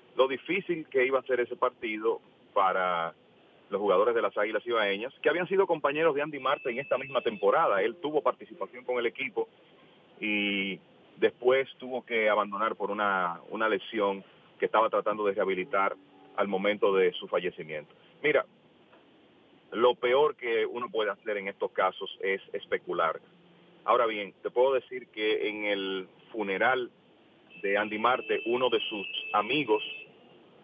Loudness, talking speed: -29 LUFS, 155 wpm